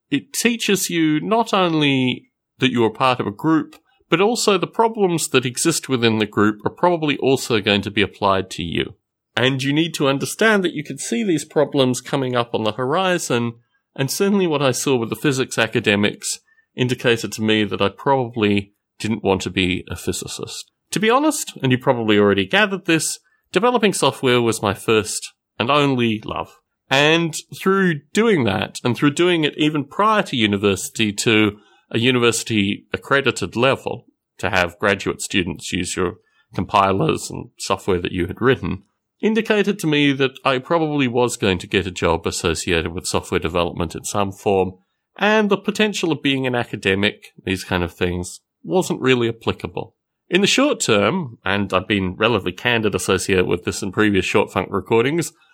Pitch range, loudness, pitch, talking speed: 100-160 Hz, -19 LUFS, 125 Hz, 175 wpm